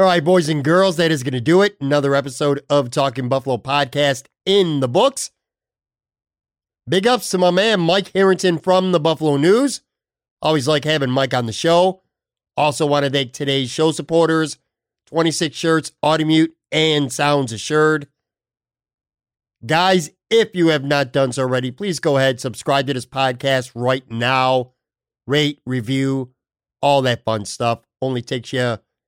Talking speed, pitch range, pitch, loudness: 155 wpm, 130-165 Hz, 145 Hz, -18 LUFS